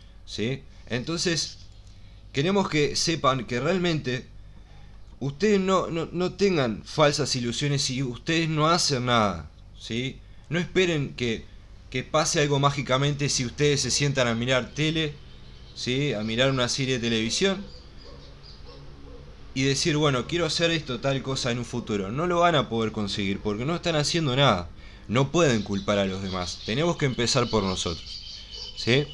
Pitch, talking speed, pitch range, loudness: 125 Hz, 155 wpm, 100-150 Hz, -25 LUFS